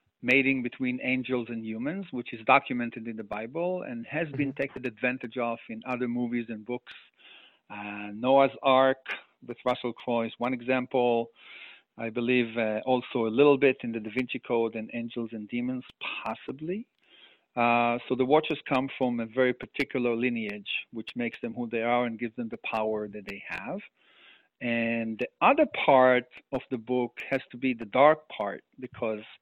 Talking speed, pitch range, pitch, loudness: 175 wpm, 115-130 Hz, 125 Hz, -28 LUFS